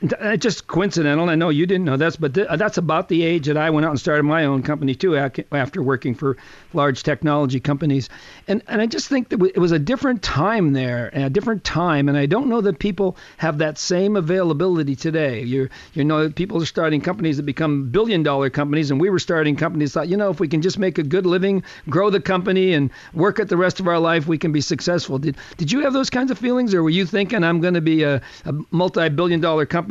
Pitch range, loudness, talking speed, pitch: 150-185 Hz, -19 LUFS, 240 wpm, 165 Hz